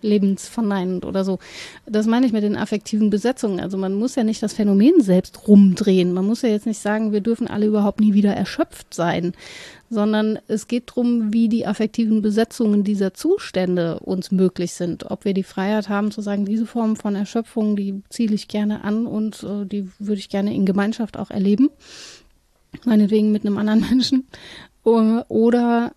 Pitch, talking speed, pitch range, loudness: 210 Hz, 180 wpm, 200-225 Hz, -20 LUFS